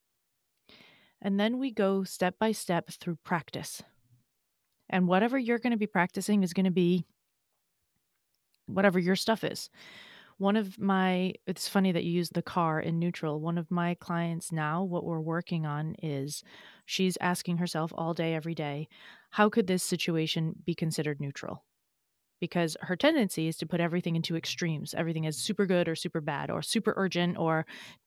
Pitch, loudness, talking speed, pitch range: 175 Hz, -30 LUFS, 170 wpm, 165-190 Hz